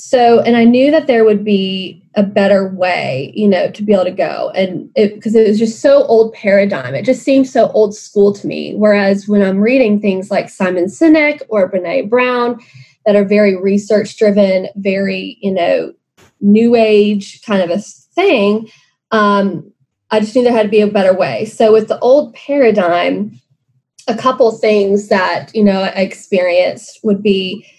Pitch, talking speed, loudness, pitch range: 205 Hz, 185 wpm, -12 LUFS, 190-225 Hz